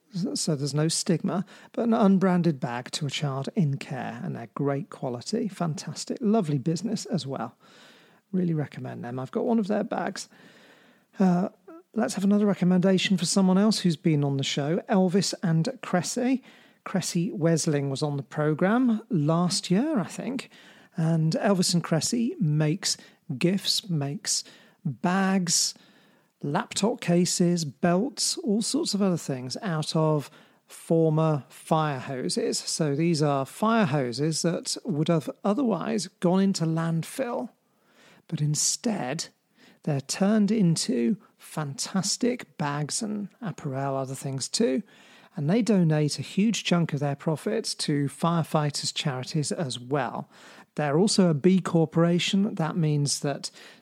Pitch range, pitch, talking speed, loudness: 155-215 Hz, 180 Hz, 140 wpm, -26 LUFS